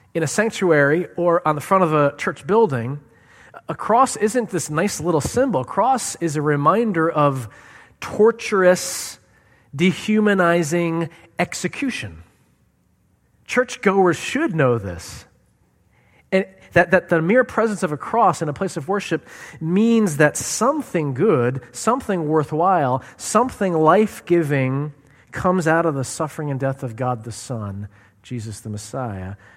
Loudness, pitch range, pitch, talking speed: -20 LUFS, 130-190 Hz, 160 Hz, 140 wpm